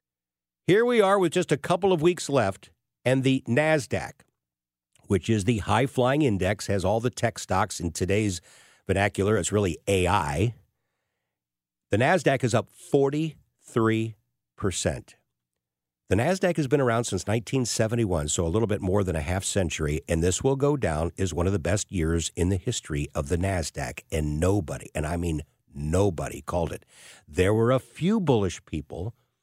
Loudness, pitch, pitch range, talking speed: -26 LUFS, 100 Hz, 85-125 Hz, 165 wpm